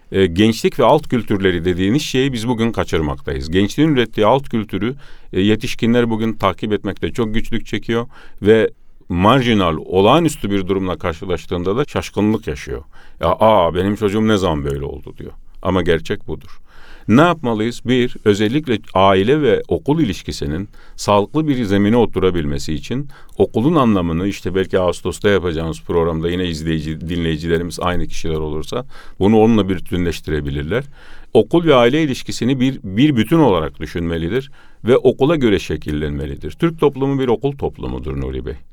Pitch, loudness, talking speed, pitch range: 100 Hz, -17 LUFS, 140 wpm, 85-120 Hz